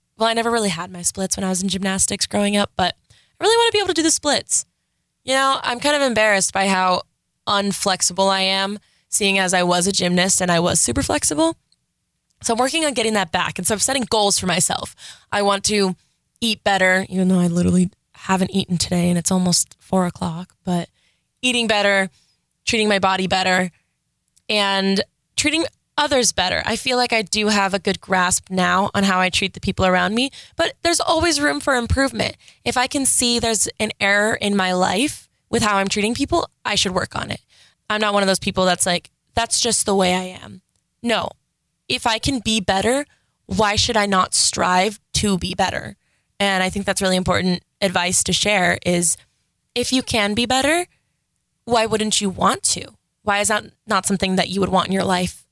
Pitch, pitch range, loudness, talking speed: 200 Hz, 185-230 Hz, -19 LUFS, 210 wpm